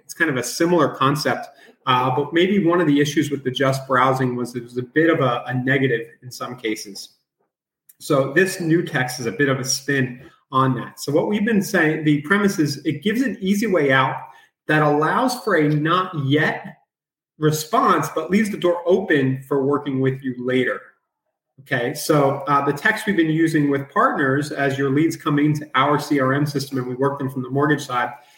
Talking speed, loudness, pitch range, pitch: 205 wpm, -20 LUFS, 130-160 Hz, 145 Hz